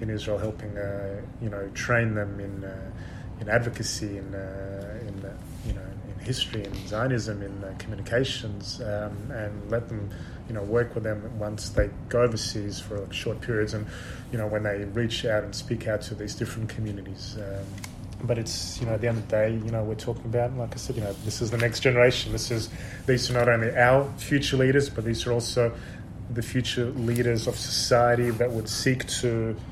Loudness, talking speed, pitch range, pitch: -27 LUFS, 205 wpm, 100-120 Hz, 110 Hz